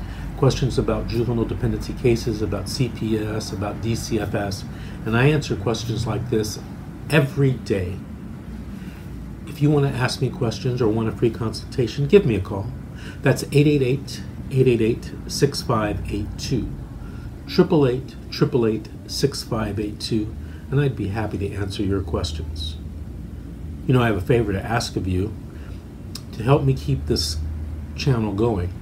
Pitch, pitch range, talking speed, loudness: 110 Hz, 100-125 Hz, 135 wpm, -22 LUFS